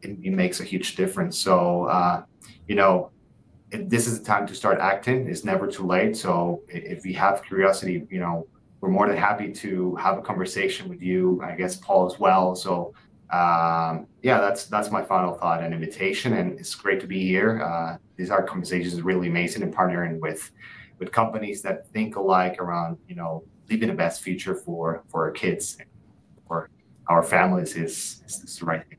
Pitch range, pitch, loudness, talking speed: 85-100 Hz, 90 Hz, -24 LUFS, 195 wpm